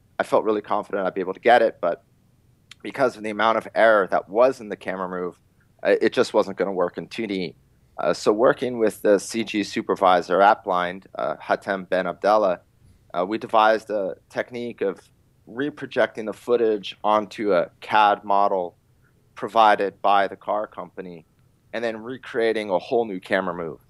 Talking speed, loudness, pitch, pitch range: 175 wpm, -22 LUFS, 110 Hz, 100-120 Hz